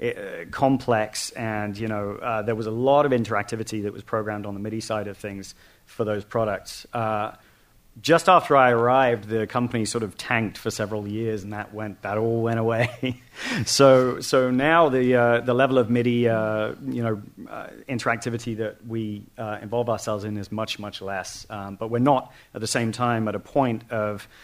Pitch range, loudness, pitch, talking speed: 105-125 Hz, -24 LUFS, 115 Hz, 195 wpm